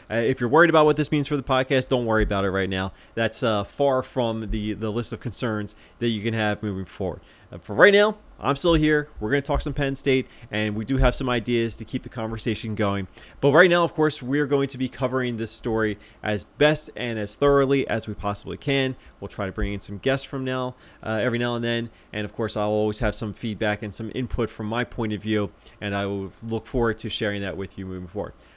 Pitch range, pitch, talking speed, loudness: 105-130 Hz, 115 Hz, 250 wpm, -24 LUFS